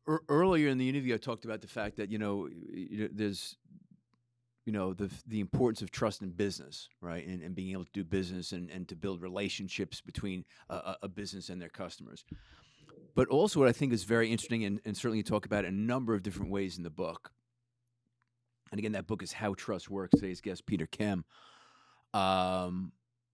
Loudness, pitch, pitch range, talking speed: -34 LUFS, 105 Hz, 95-120 Hz, 205 wpm